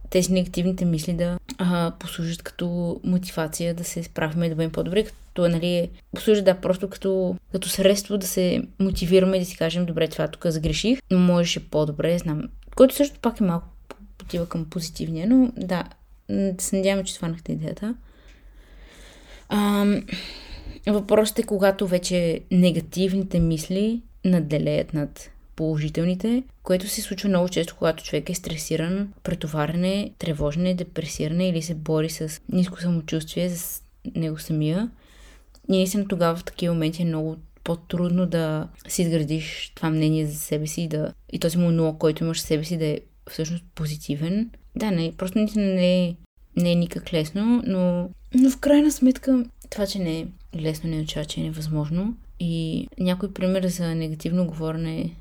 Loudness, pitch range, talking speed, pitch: -24 LUFS, 160-195 Hz, 160 wpm, 175 Hz